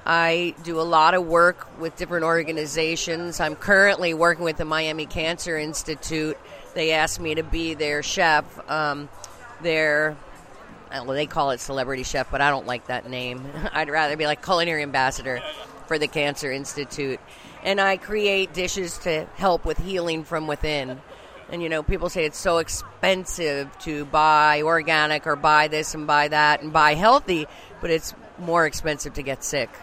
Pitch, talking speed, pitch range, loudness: 155 Hz, 170 wpm, 145-170 Hz, -22 LUFS